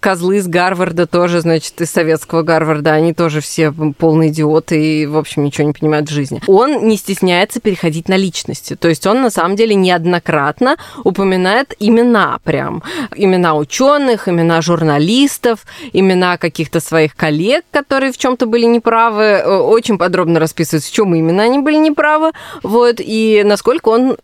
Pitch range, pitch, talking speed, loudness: 160-225 Hz, 180 Hz, 160 wpm, -13 LUFS